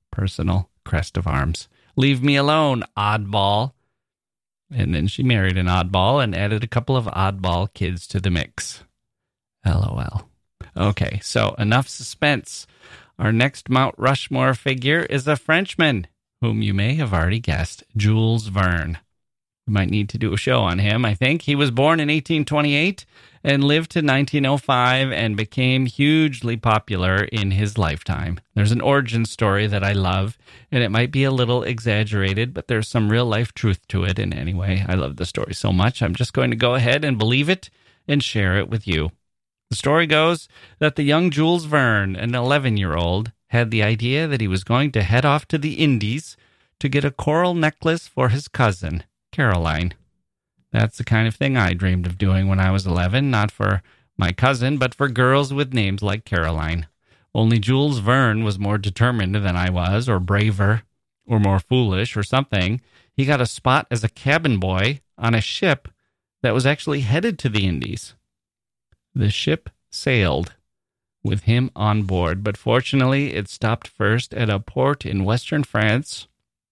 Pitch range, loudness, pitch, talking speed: 100-135 Hz, -20 LUFS, 115 Hz, 175 wpm